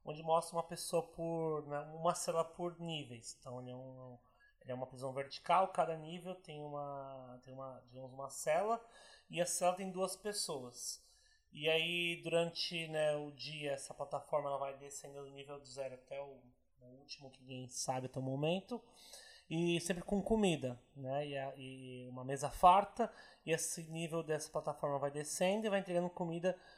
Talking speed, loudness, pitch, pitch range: 180 wpm, -39 LUFS, 155 Hz, 135-175 Hz